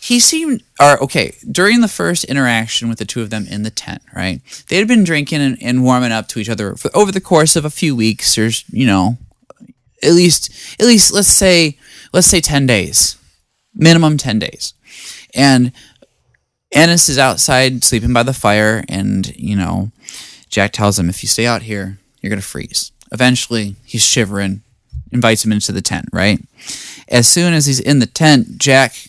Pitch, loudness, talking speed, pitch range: 125 Hz, -12 LUFS, 190 wpm, 110-155 Hz